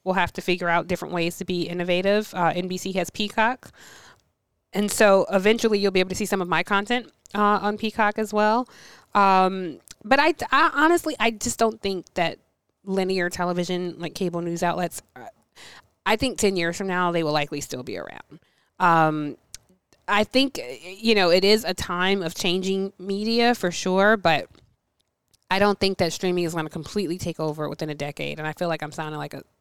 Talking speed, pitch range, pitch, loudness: 195 wpm, 170-210 Hz, 185 Hz, -23 LUFS